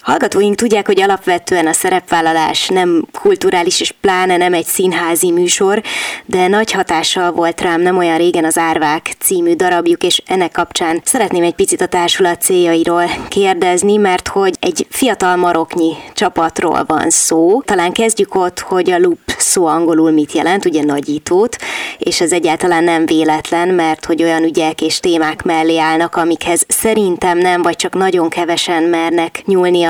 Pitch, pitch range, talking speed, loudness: 180 Hz, 165-210 Hz, 155 wpm, -13 LUFS